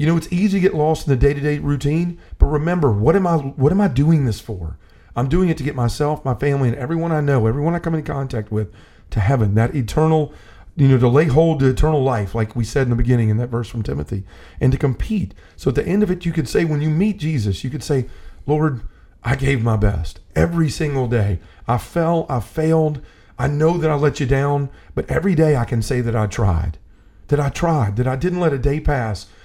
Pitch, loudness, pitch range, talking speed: 135 Hz, -19 LUFS, 115-155 Hz, 245 wpm